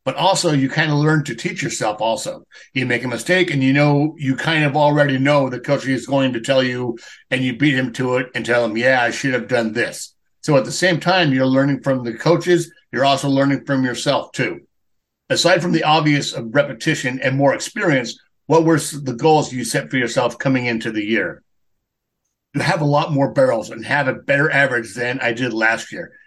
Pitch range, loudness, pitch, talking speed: 125-155 Hz, -18 LUFS, 140 Hz, 220 wpm